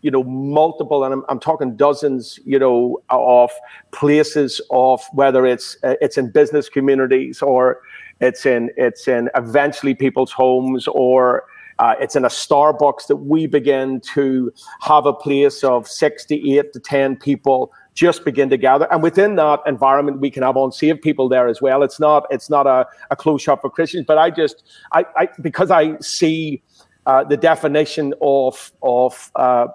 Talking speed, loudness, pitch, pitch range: 175 wpm, -16 LUFS, 140 Hz, 130-150 Hz